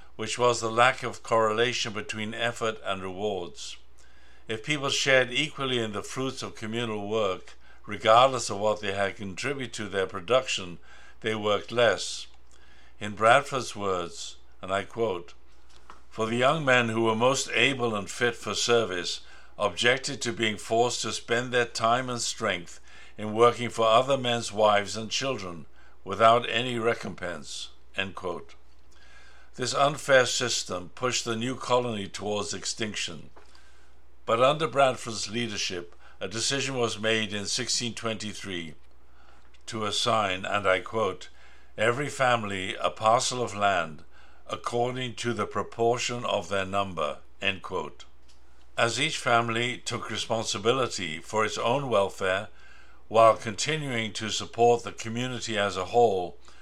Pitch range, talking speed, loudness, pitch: 100-120 Hz, 140 wpm, -27 LUFS, 110 Hz